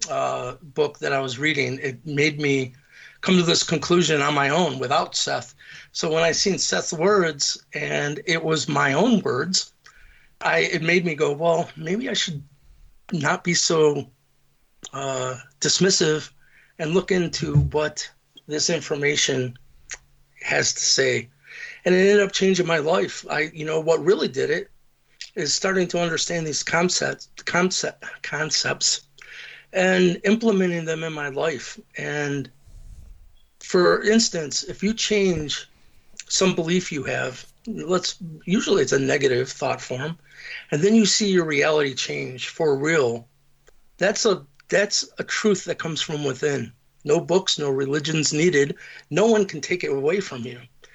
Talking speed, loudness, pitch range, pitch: 155 wpm, -22 LUFS, 145-185 Hz, 160 Hz